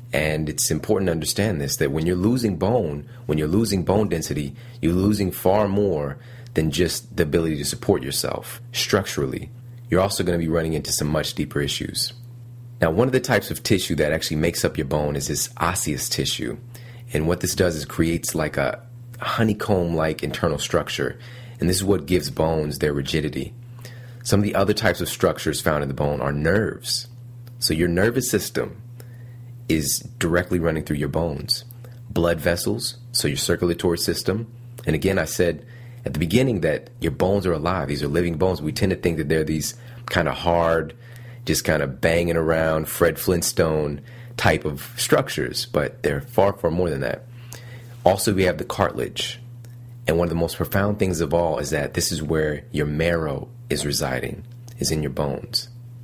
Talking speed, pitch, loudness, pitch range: 185 wpm, 95 Hz, -22 LUFS, 80-120 Hz